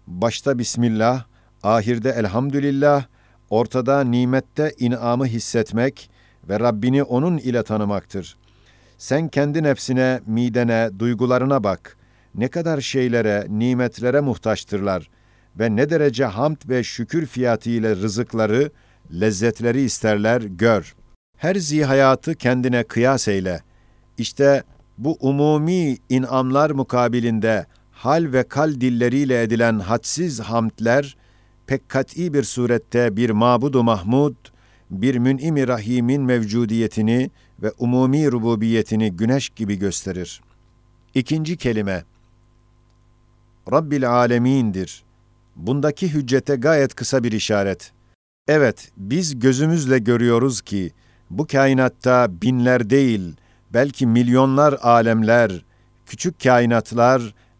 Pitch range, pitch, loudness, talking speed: 115-135 Hz, 120 Hz, -19 LUFS, 100 wpm